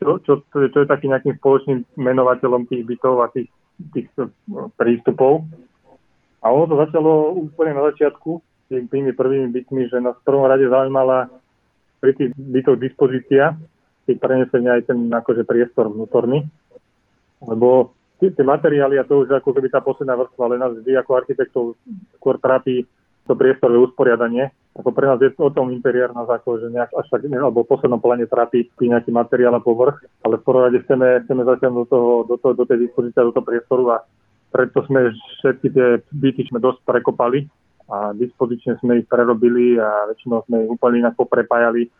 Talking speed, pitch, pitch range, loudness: 170 wpm, 125 Hz, 120-135 Hz, -17 LUFS